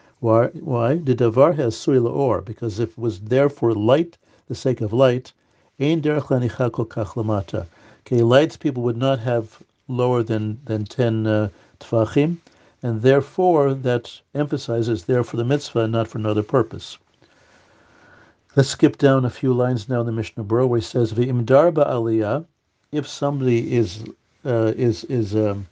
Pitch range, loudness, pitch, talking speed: 115-135 Hz, -20 LUFS, 120 Hz, 145 wpm